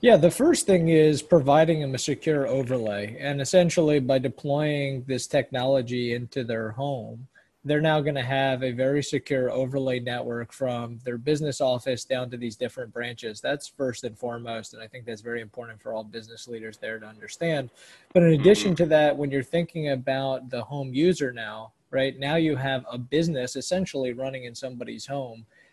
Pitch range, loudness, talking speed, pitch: 120-145 Hz, -25 LUFS, 185 wpm, 135 Hz